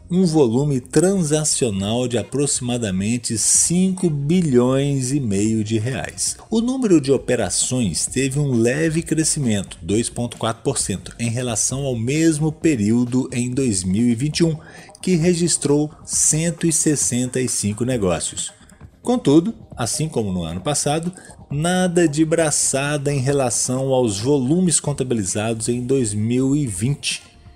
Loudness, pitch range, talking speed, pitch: -19 LUFS, 115-155 Hz, 100 wpm, 135 Hz